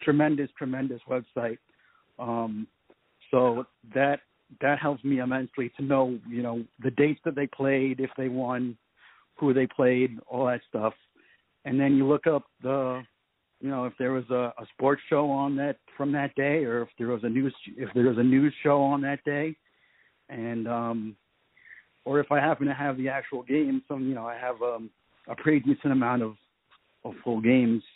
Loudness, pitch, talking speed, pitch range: -27 LUFS, 130 Hz, 190 wpm, 120-140 Hz